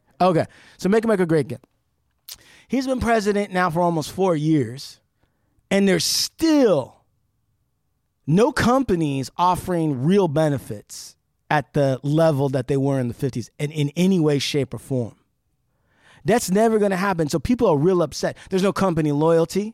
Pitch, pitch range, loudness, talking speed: 160 Hz, 140-190 Hz, -21 LUFS, 165 wpm